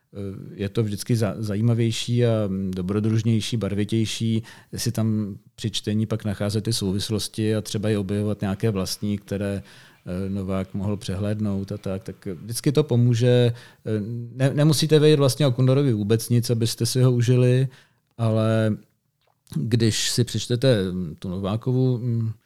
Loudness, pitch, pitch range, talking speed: -23 LUFS, 110 Hz, 105-120 Hz, 130 wpm